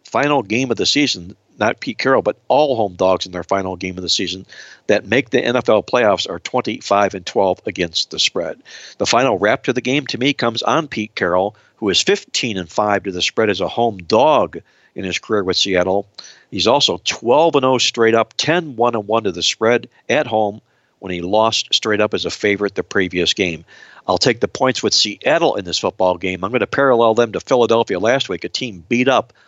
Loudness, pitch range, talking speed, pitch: -17 LUFS, 95-120 Hz, 220 wpm, 105 Hz